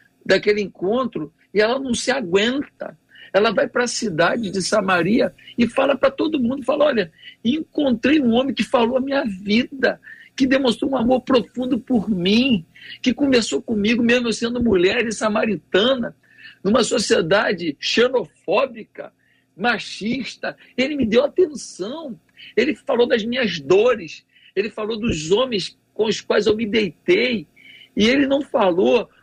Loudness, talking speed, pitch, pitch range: -20 LUFS, 150 wpm, 240 Hz, 210-270 Hz